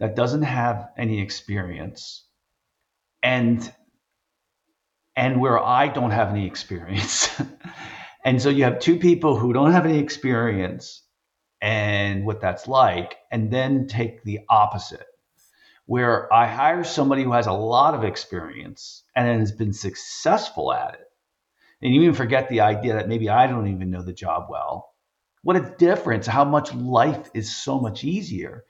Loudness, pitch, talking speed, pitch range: -21 LUFS, 120 Hz, 155 wpm, 105-135 Hz